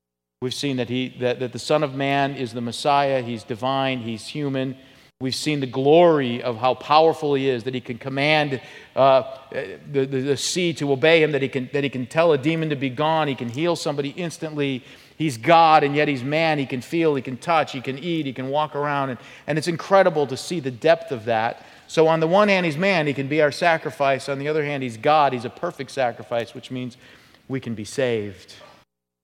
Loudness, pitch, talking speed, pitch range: -21 LUFS, 140 Hz, 230 wpm, 125-155 Hz